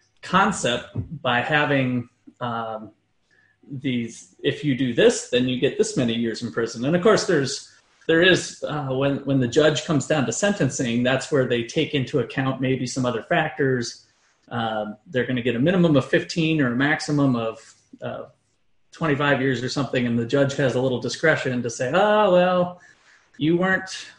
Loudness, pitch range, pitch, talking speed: -22 LUFS, 125-155 Hz, 135 Hz, 180 wpm